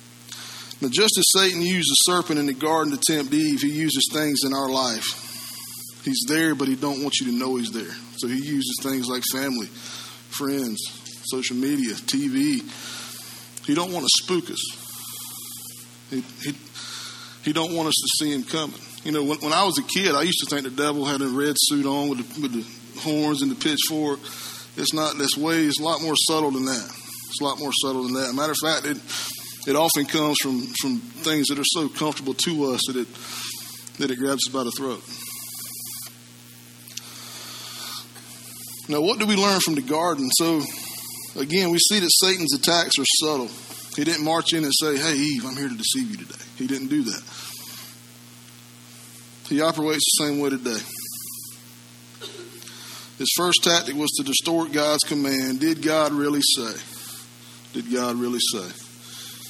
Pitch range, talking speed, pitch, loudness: 120-155 Hz, 185 wpm, 140 Hz, -22 LUFS